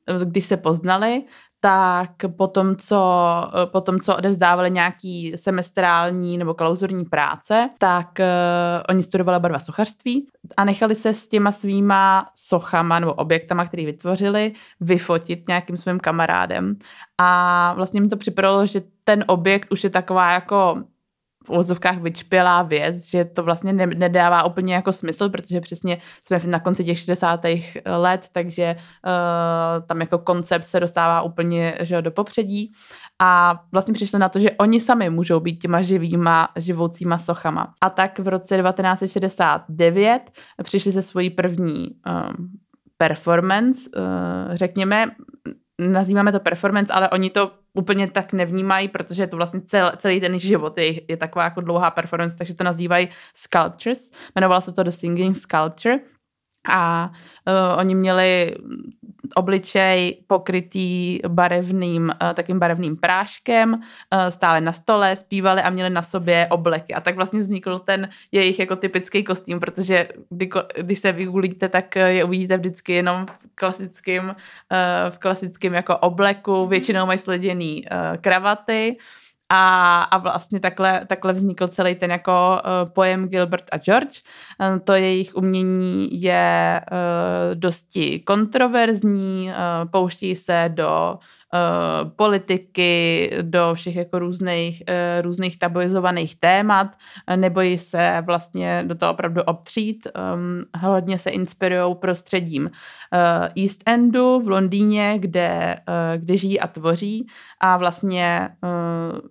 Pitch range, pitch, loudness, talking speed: 175-195 Hz, 185 Hz, -20 LUFS, 130 wpm